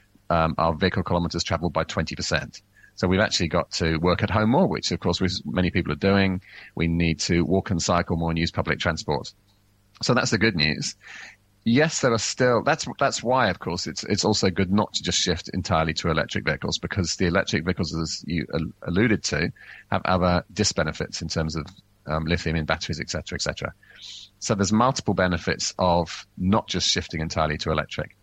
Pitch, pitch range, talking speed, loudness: 90 Hz, 80-100 Hz, 200 wpm, -24 LUFS